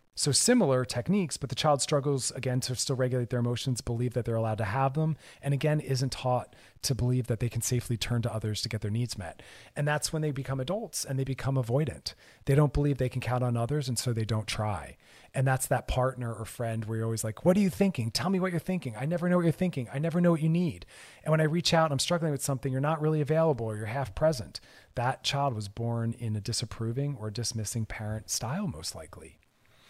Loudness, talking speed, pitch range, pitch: -29 LUFS, 245 wpm, 115-150 Hz, 130 Hz